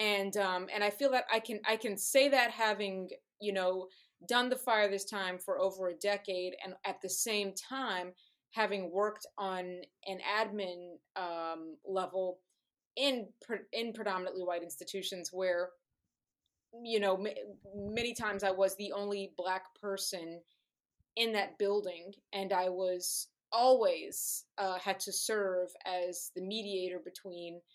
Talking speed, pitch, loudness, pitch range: 145 wpm, 195 Hz, -35 LUFS, 185-215 Hz